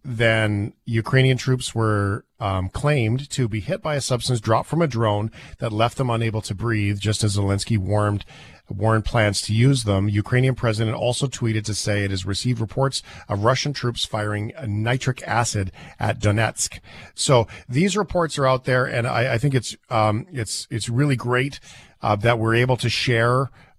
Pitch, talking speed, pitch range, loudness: 115 Hz, 180 wpm, 105-130 Hz, -22 LUFS